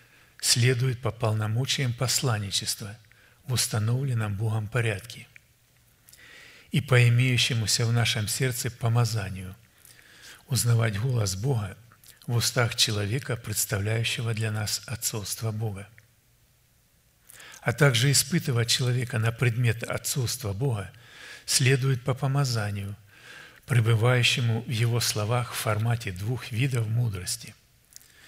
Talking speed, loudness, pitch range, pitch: 100 wpm, -26 LUFS, 110-125 Hz, 120 Hz